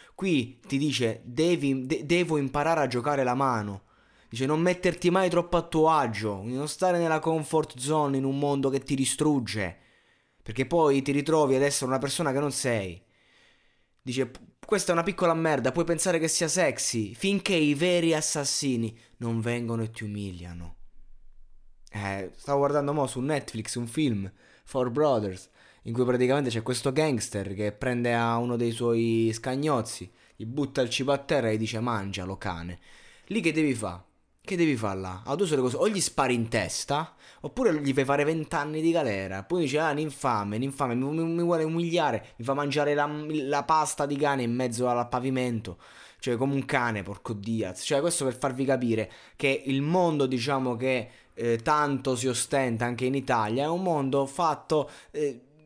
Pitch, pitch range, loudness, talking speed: 135 Hz, 115-150 Hz, -27 LUFS, 180 wpm